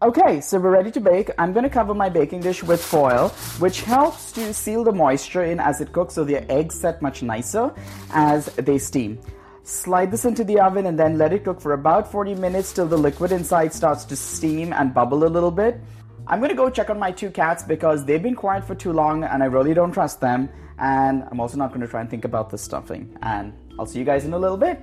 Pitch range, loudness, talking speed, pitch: 135-190 Hz, -21 LUFS, 240 wpm, 160 Hz